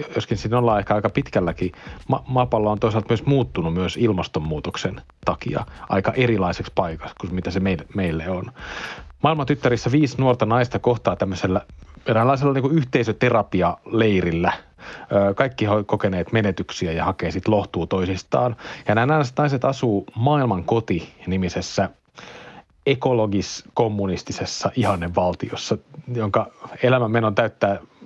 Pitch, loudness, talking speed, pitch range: 110 Hz, -22 LUFS, 120 wpm, 95-125 Hz